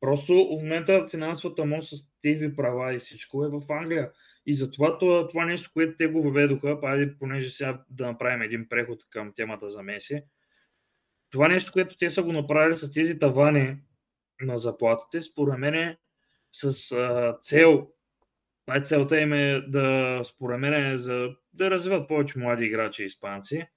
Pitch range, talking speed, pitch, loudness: 130-160 Hz, 165 wpm, 145 Hz, -25 LUFS